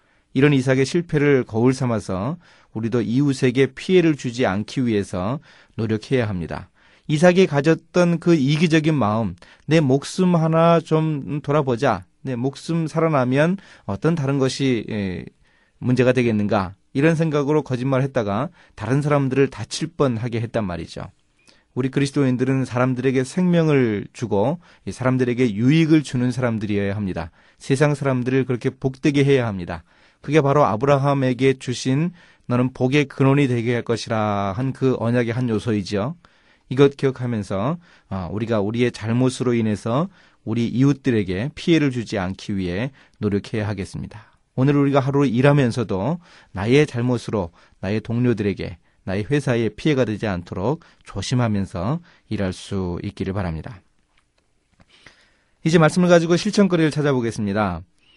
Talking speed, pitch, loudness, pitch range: 330 characters per minute, 130 Hz, -20 LUFS, 110-145 Hz